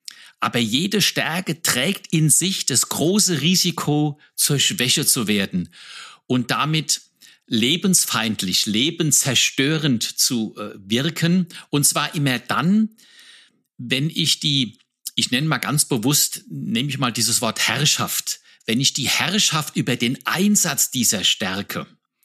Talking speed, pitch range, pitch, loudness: 125 wpm, 125-165 Hz, 145 Hz, -19 LUFS